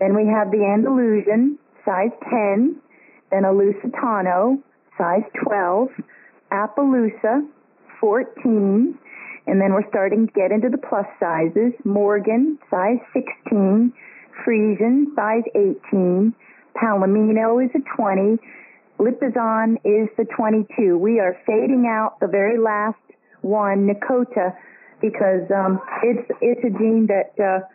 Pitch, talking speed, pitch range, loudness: 220 Hz, 120 wpm, 205-245 Hz, -19 LUFS